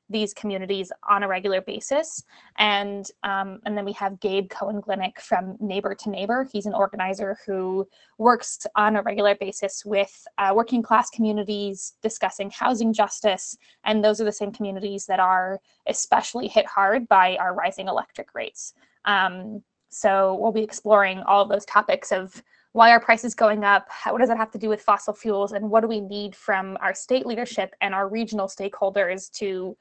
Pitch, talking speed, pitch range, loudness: 205 Hz, 180 wpm, 195-220 Hz, -23 LUFS